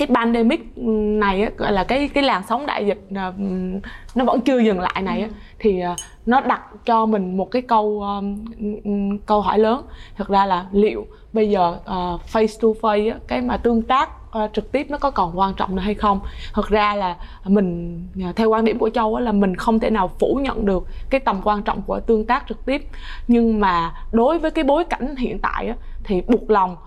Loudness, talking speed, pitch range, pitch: -20 LUFS, 215 wpm, 195-230 Hz, 215 Hz